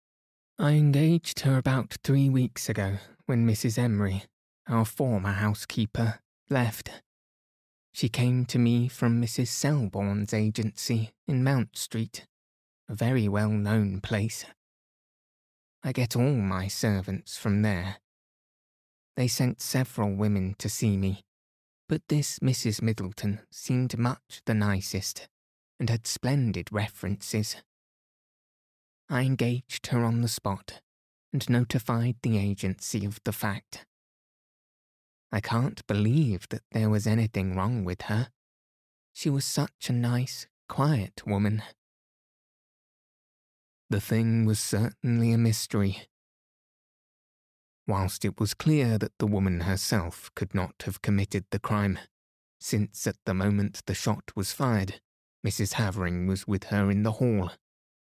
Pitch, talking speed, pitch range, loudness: 110 Hz, 125 wpm, 100-120 Hz, -28 LUFS